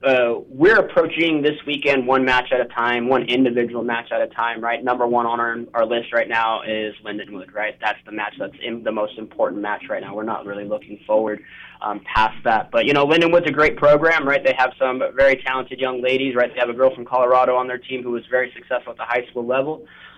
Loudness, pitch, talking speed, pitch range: -19 LUFS, 125 Hz, 240 wpm, 115-135 Hz